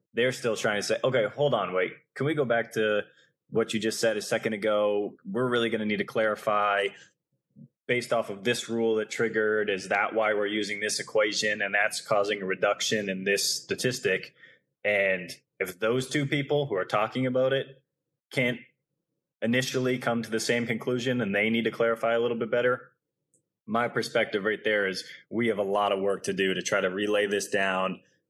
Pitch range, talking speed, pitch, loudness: 105-120 Hz, 200 wpm, 110 Hz, -27 LUFS